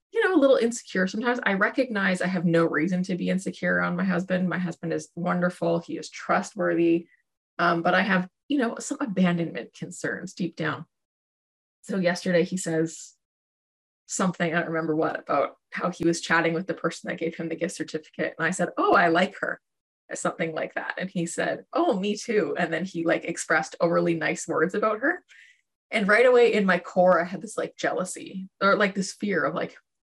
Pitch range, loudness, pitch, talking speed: 165-195 Hz, -25 LUFS, 175 Hz, 205 wpm